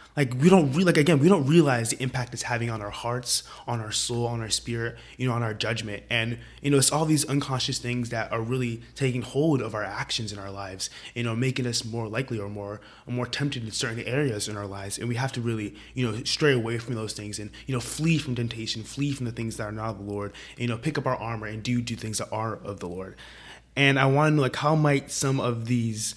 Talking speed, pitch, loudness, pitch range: 270 wpm, 120 Hz, -26 LUFS, 110-135 Hz